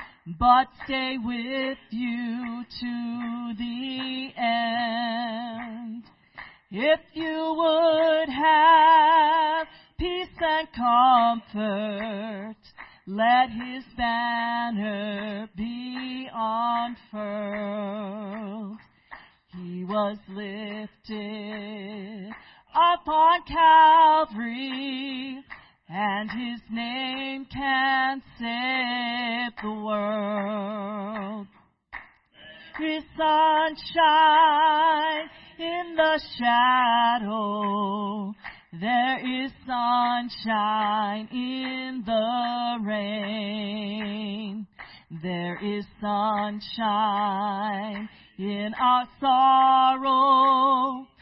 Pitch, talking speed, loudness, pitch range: 235 Hz, 55 wpm, -24 LUFS, 210-265 Hz